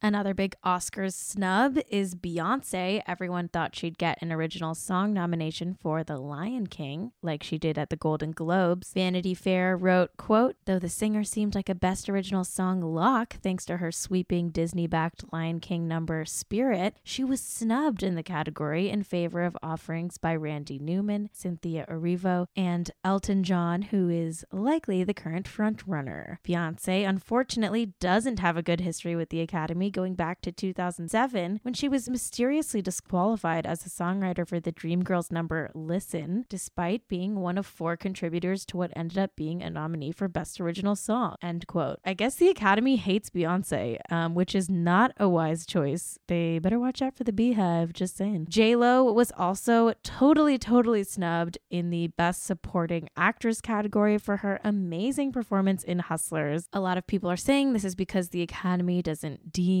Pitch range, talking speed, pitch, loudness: 170-205 Hz, 175 wpm, 180 Hz, -28 LUFS